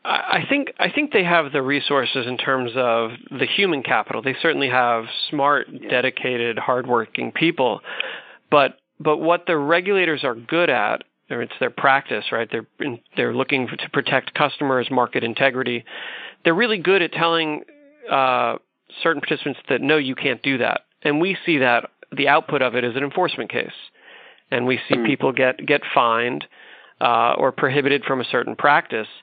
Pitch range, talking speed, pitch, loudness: 125-165 Hz, 170 wpm, 140 Hz, -20 LUFS